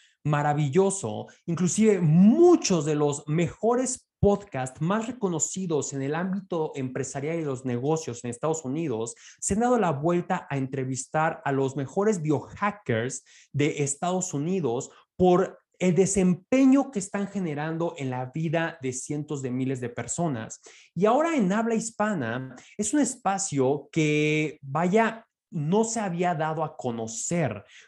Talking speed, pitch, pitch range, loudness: 140 wpm, 160 Hz, 140-195 Hz, -26 LUFS